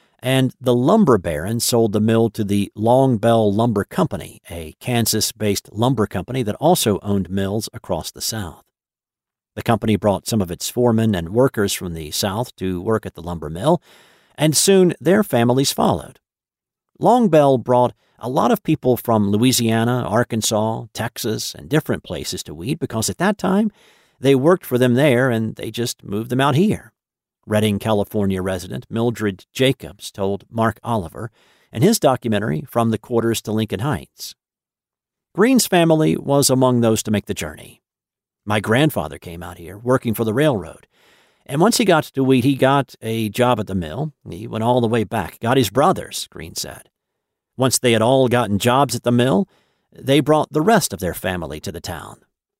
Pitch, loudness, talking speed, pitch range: 115 Hz, -19 LUFS, 175 wpm, 105-130 Hz